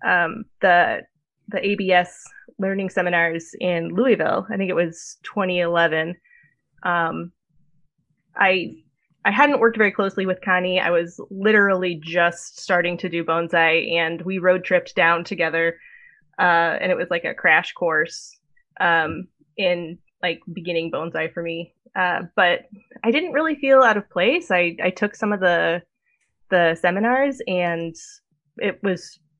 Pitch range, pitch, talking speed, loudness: 170-205 Hz, 180 Hz, 145 wpm, -20 LUFS